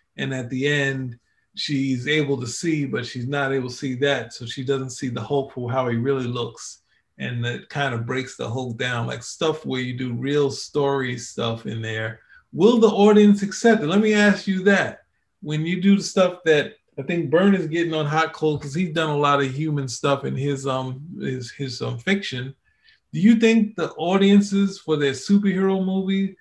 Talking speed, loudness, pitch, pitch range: 210 wpm, -22 LUFS, 145 Hz, 130-185 Hz